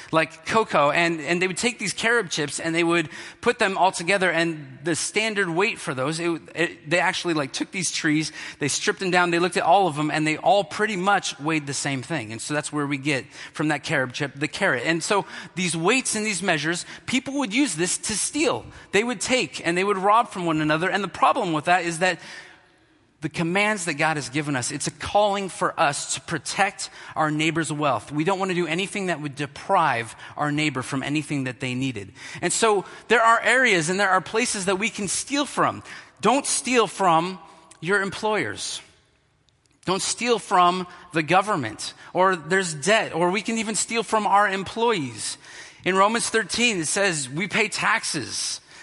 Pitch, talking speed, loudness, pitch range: 175 Hz, 205 wpm, -23 LUFS, 155-205 Hz